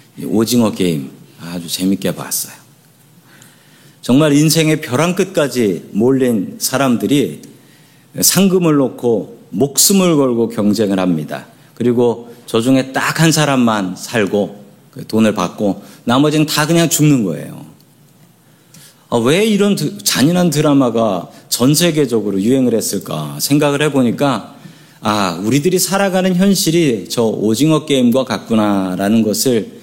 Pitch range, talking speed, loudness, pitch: 110-155 Hz, 265 characters per minute, -14 LUFS, 130 Hz